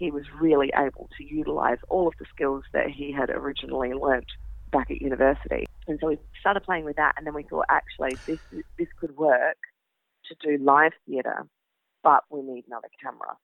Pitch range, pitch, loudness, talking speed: 135-170 Hz, 145 Hz, -26 LUFS, 190 wpm